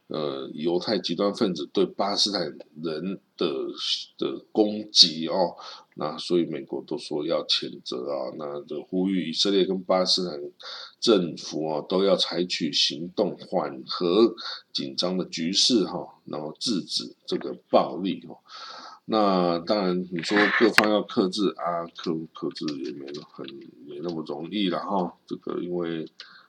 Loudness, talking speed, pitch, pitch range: -25 LUFS, 225 characters per minute, 90 Hz, 85-105 Hz